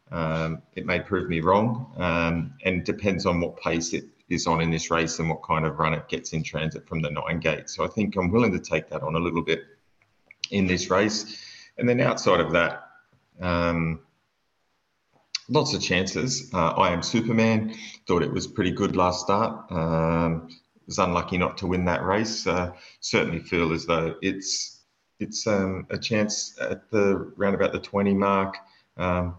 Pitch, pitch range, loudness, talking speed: 90 Hz, 80-100 Hz, -25 LUFS, 190 wpm